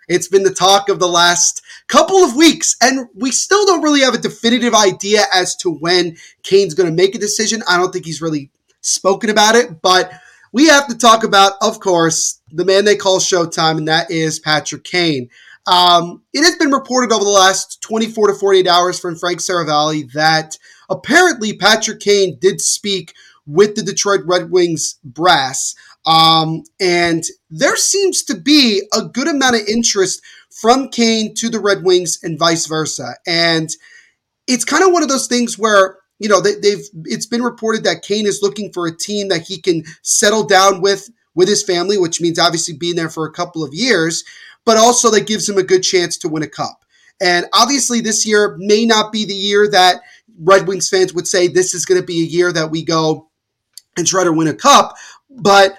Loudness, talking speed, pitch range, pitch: -13 LUFS, 200 wpm, 175-220 Hz, 190 Hz